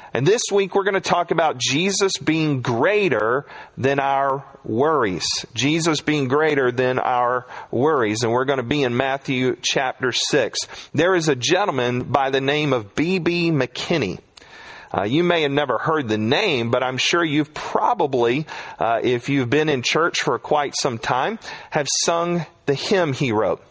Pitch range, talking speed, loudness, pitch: 130-165 Hz, 170 wpm, -20 LUFS, 140 Hz